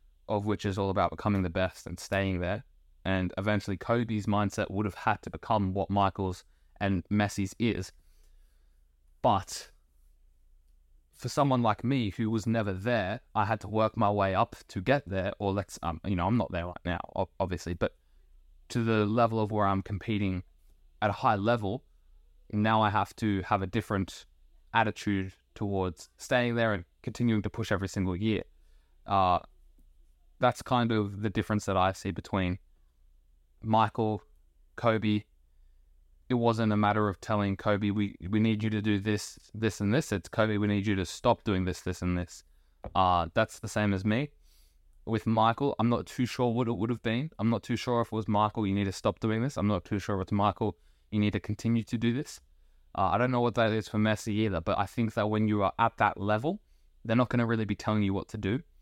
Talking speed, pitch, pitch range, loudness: 205 wpm, 105 Hz, 90-110 Hz, -30 LUFS